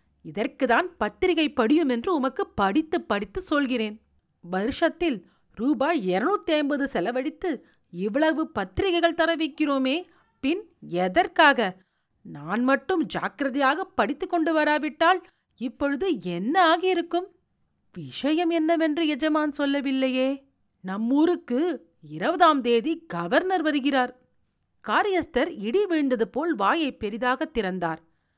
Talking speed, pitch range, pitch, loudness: 90 wpm, 235-330 Hz, 285 Hz, -24 LUFS